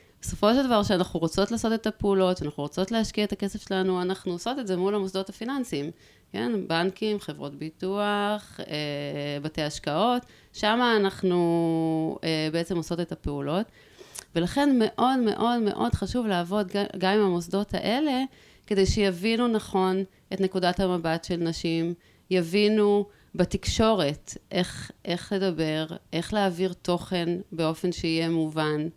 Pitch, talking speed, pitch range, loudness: 190 Hz, 130 wpm, 170-210 Hz, -26 LUFS